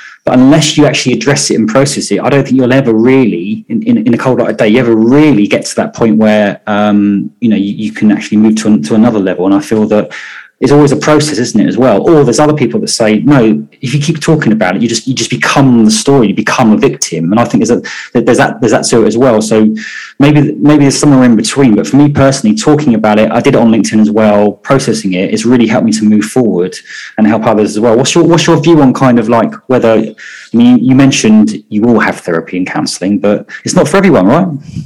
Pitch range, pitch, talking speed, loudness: 110-145 Hz, 120 Hz, 265 wpm, -8 LUFS